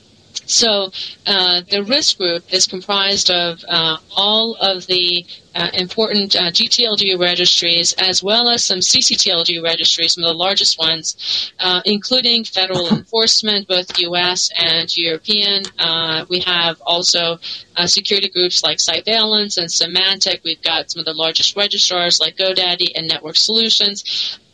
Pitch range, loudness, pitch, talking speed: 170-200 Hz, -14 LUFS, 180 Hz, 145 wpm